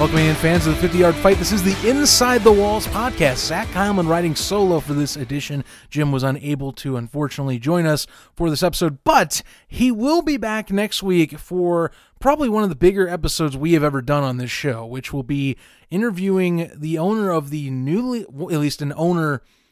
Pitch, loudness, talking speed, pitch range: 165 Hz, -19 LUFS, 205 wpm, 145-195 Hz